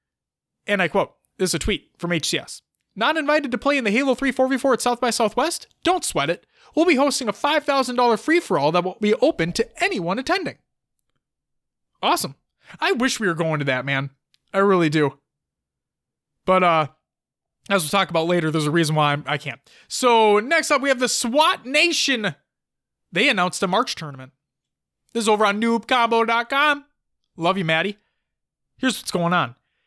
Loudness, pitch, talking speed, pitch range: -20 LUFS, 210 Hz, 175 wpm, 165-260 Hz